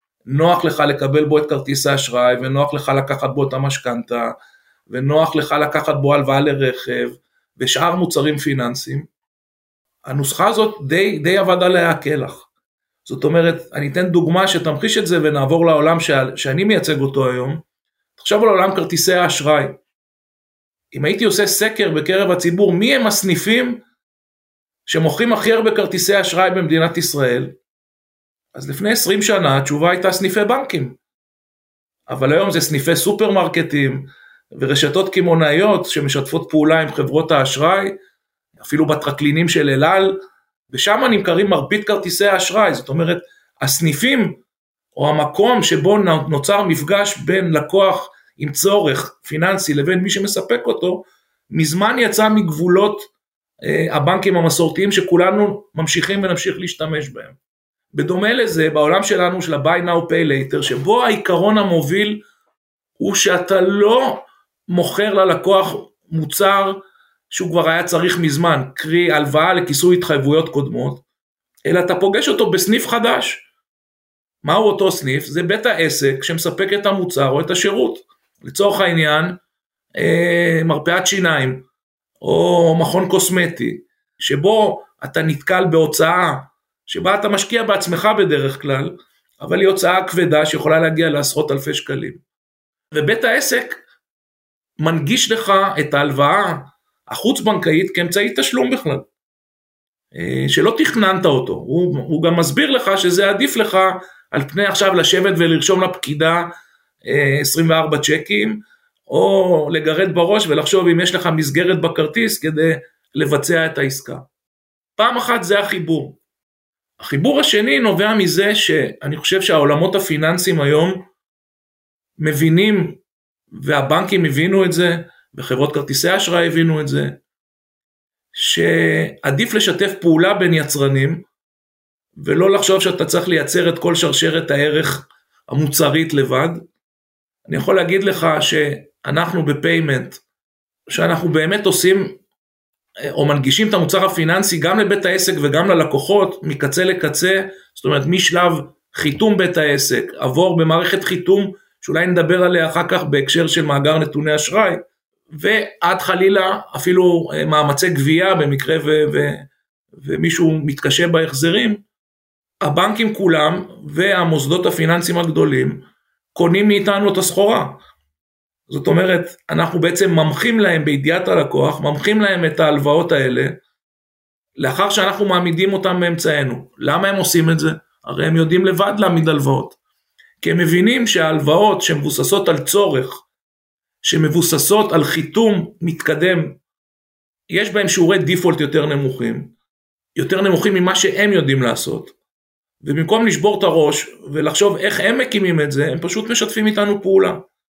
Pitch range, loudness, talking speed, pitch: 150-195 Hz, -16 LUFS, 120 wpm, 170 Hz